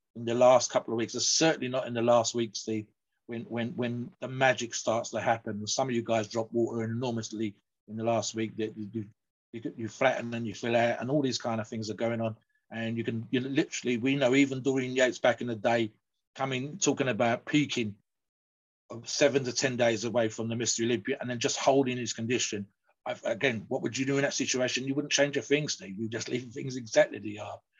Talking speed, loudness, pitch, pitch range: 230 wpm, -29 LUFS, 120 Hz, 115-130 Hz